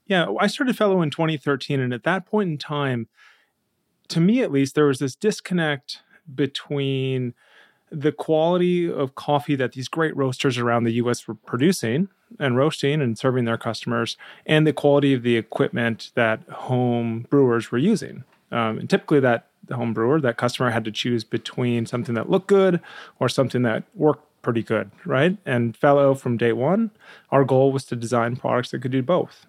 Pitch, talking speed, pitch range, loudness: 135 Hz, 185 wpm, 120-160 Hz, -22 LUFS